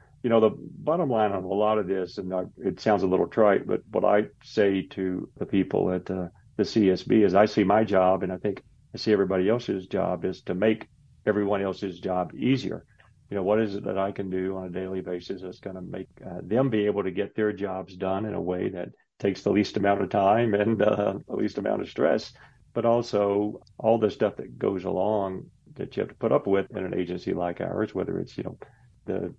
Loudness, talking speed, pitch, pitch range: -26 LUFS, 235 wpm, 100 Hz, 95-105 Hz